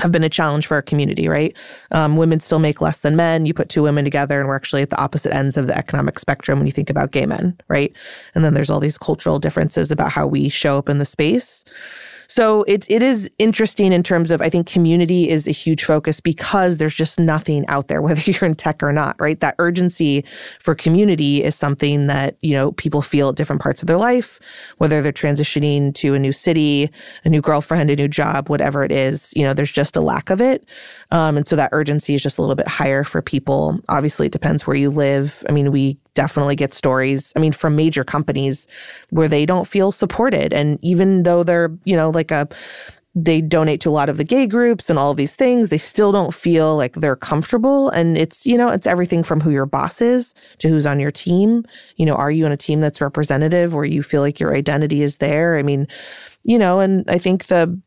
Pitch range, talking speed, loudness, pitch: 145-175 Hz, 235 wpm, -17 LUFS, 155 Hz